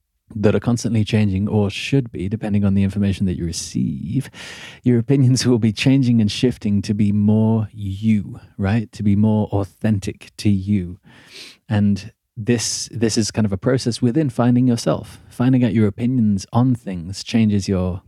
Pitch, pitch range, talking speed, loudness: 110 Hz, 100-120 Hz, 170 wpm, -19 LUFS